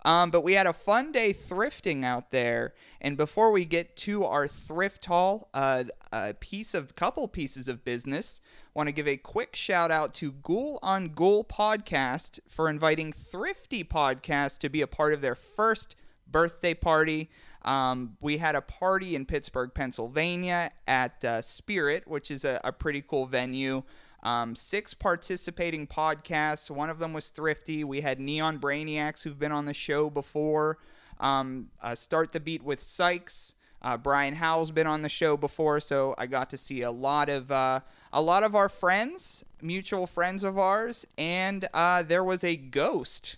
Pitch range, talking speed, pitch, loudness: 140-175 Hz, 175 wpm, 155 Hz, -29 LUFS